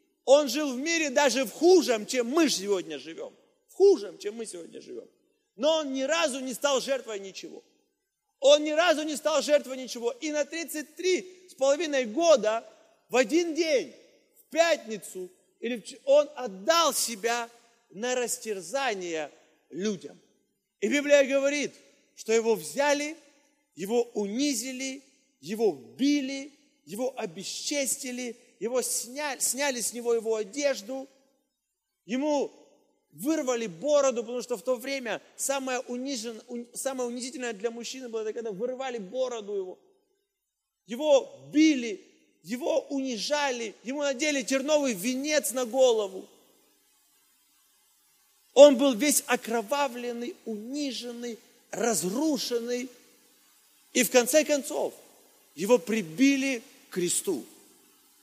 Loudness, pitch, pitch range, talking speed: -27 LUFS, 265 Hz, 235-295 Hz, 115 wpm